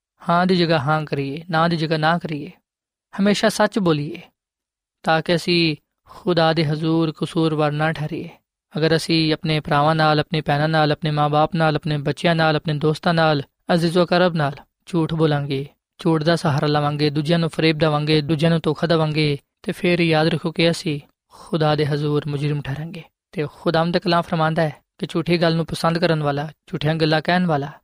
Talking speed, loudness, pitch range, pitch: 175 wpm, -20 LUFS, 150-170 Hz, 160 Hz